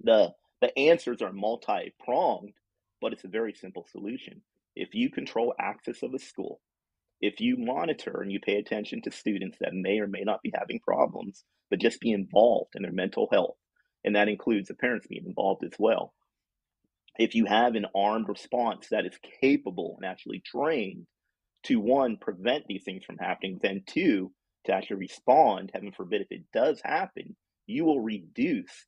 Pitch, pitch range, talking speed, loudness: 110 Hz, 100-135 Hz, 180 wpm, -29 LUFS